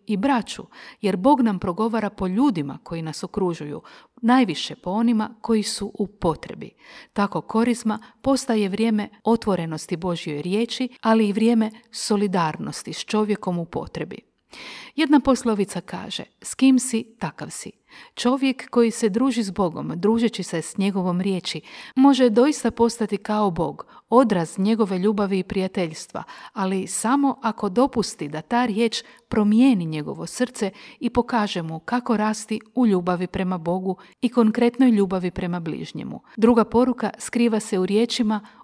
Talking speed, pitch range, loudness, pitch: 145 wpm, 190-240 Hz, -22 LUFS, 215 Hz